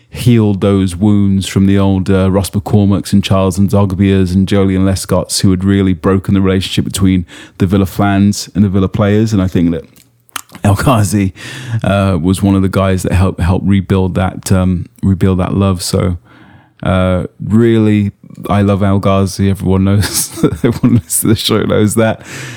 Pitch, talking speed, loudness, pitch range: 100 Hz, 180 wpm, -12 LUFS, 95-100 Hz